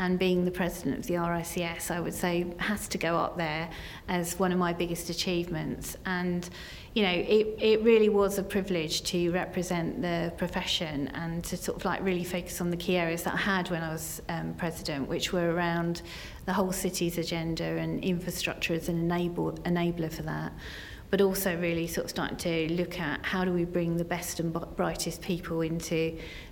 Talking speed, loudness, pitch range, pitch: 195 wpm, -30 LUFS, 165-185 Hz, 175 Hz